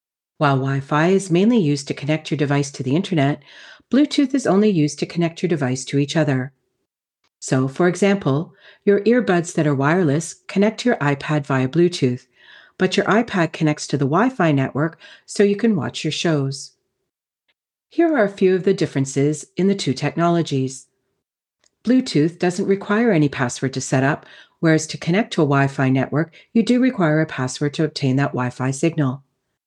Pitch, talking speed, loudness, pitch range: 155 Hz, 175 wpm, -19 LUFS, 140-190 Hz